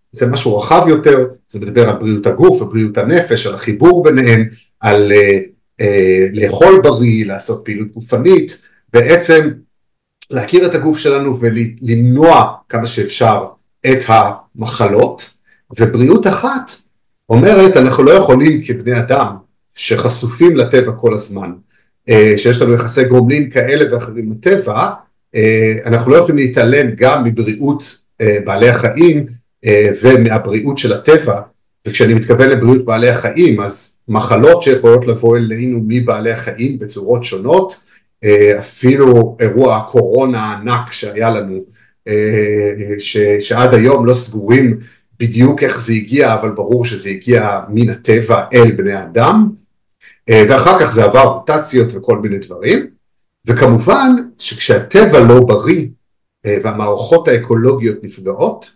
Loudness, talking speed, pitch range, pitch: -10 LUFS, 120 wpm, 110-135 Hz, 120 Hz